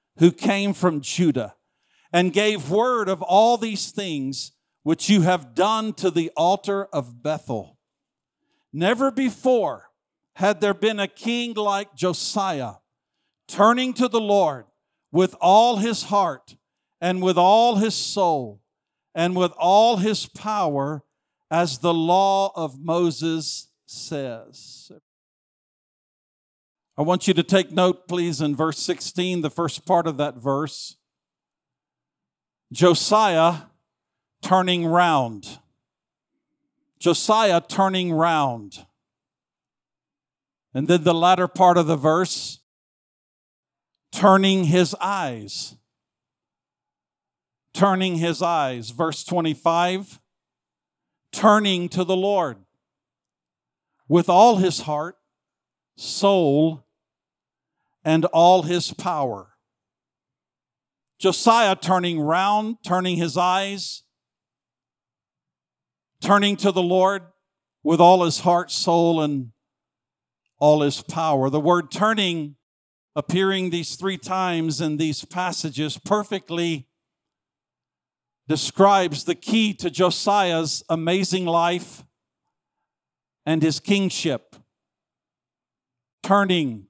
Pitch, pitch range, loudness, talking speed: 175 Hz, 155-195 Hz, -21 LUFS, 100 wpm